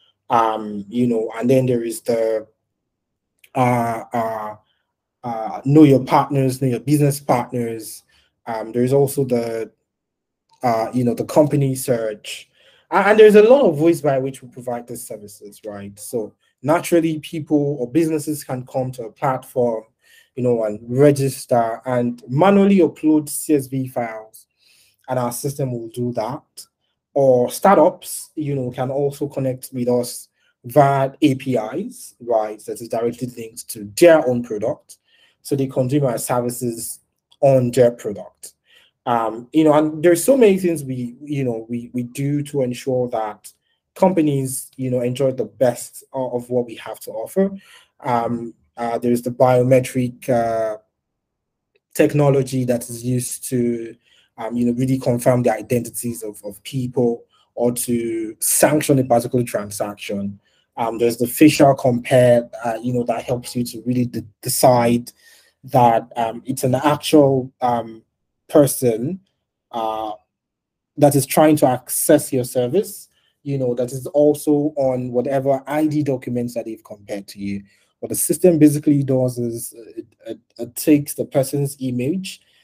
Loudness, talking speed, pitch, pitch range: -19 LUFS, 155 wpm, 125 Hz, 115-140 Hz